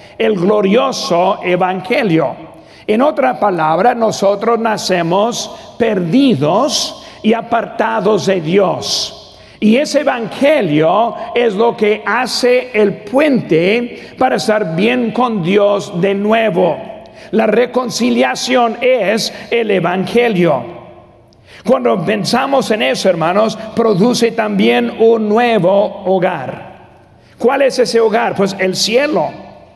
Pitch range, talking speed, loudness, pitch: 195-240 Hz, 105 wpm, -13 LUFS, 220 Hz